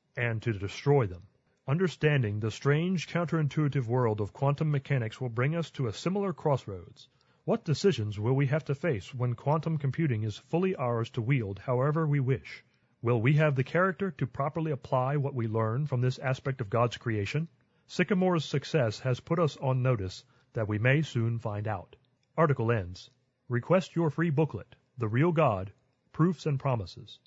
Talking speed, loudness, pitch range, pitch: 175 wpm, -30 LUFS, 120-155 Hz, 135 Hz